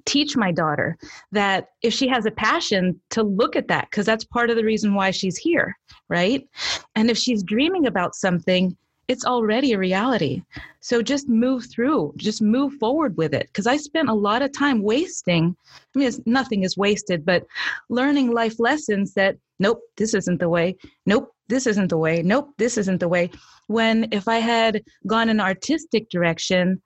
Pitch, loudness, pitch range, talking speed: 220 Hz, -21 LUFS, 190-245 Hz, 190 wpm